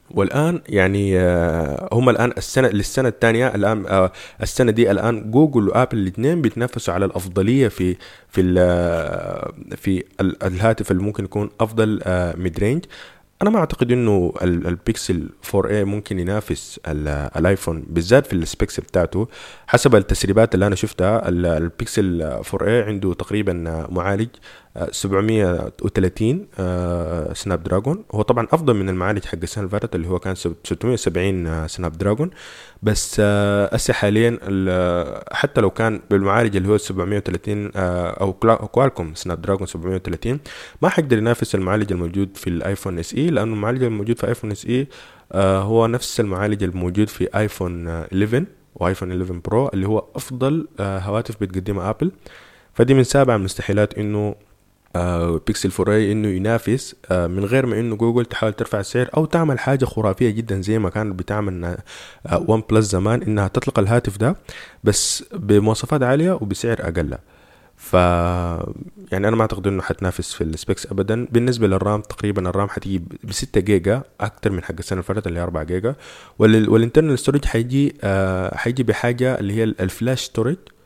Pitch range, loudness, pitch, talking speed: 90-115 Hz, -20 LUFS, 105 Hz, 145 wpm